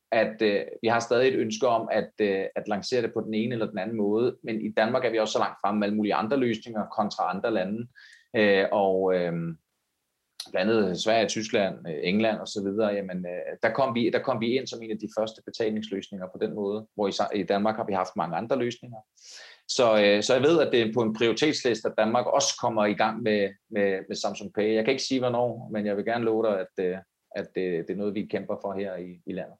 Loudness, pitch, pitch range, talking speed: -26 LUFS, 105 Hz, 100-115 Hz, 240 wpm